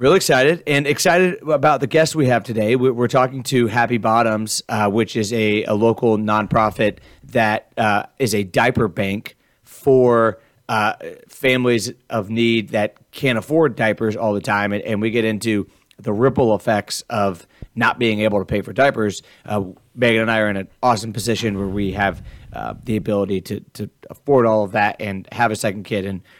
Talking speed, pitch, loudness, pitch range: 185 wpm, 110 Hz, -18 LUFS, 105-120 Hz